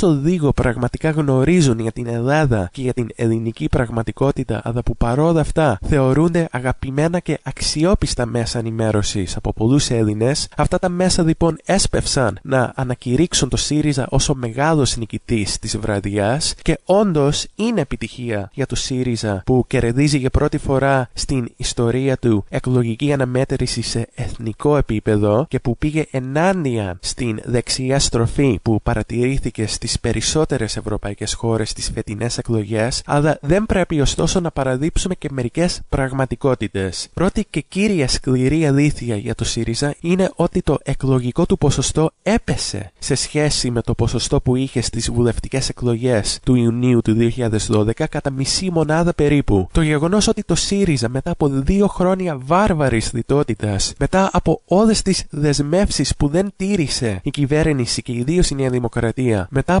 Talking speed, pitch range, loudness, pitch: 145 wpm, 115-155 Hz, -18 LUFS, 130 Hz